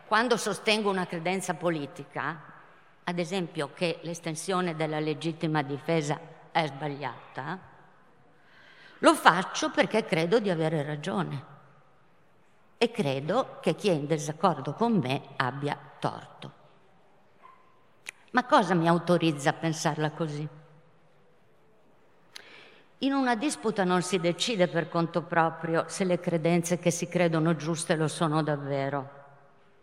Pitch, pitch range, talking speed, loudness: 170 Hz, 155-185 Hz, 115 wpm, -28 LUFS